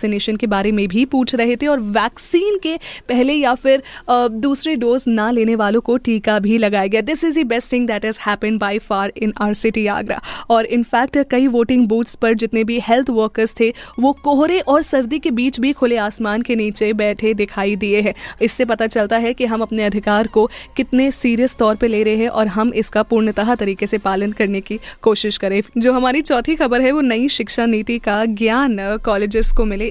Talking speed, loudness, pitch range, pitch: 210 wpm, -17 LUFS, 215-250 Hz, 230 Hz